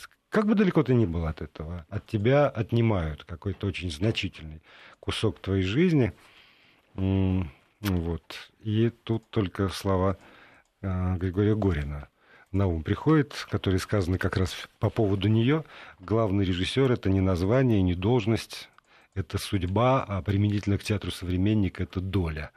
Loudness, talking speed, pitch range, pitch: -27 LUFS, 135 wpm, 90-110 Hz, 100 Hz